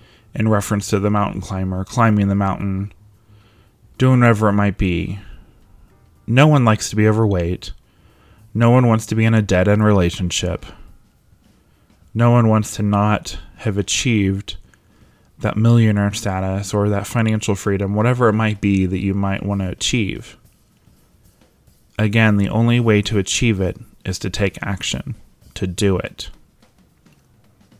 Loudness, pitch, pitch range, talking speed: -18 LUFS, 105 Hz, 95-110 Hz, 145 wpm